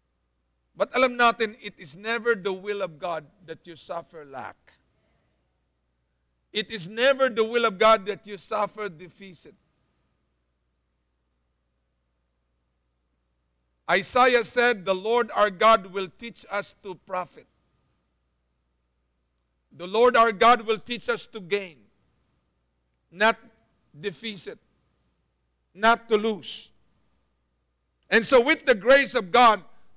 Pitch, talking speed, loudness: 185 Hz, 110 wpm, -23 LUFS